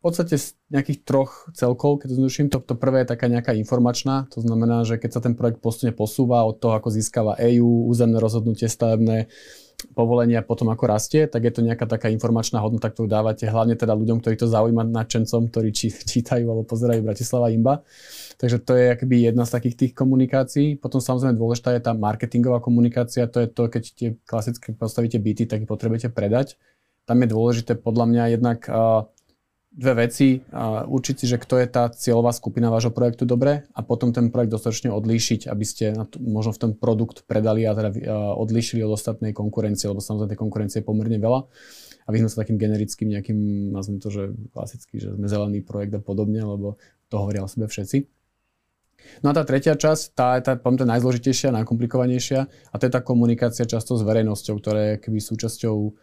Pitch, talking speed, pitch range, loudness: 115 Hz, 190 wpm, 110-125 Hz, -22 LUFS